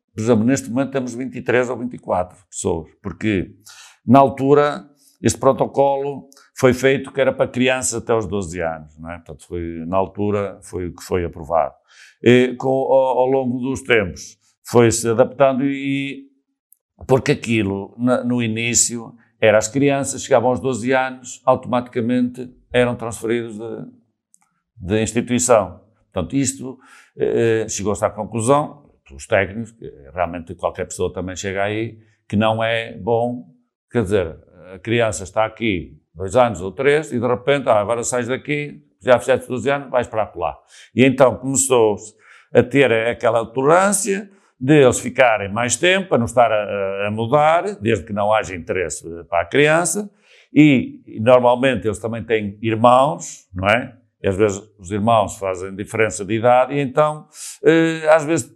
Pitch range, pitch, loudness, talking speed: 105-135 Hz, 120 Hz, -18 LUFS, 155 wpm